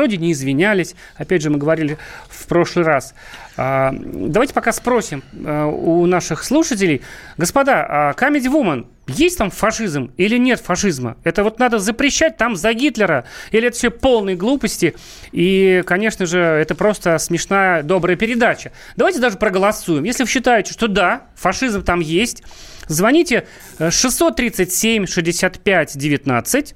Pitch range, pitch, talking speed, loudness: 170-240 Hz, 195 Hz, 140 wpm, -16 LUFS